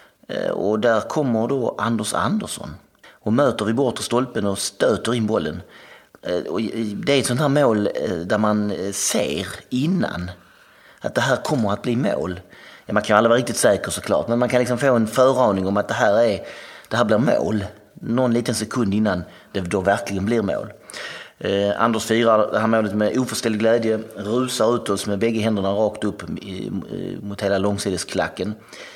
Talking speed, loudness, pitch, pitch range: 170 wpm, -21 LUFS, 110 Hz, 100-120 Hz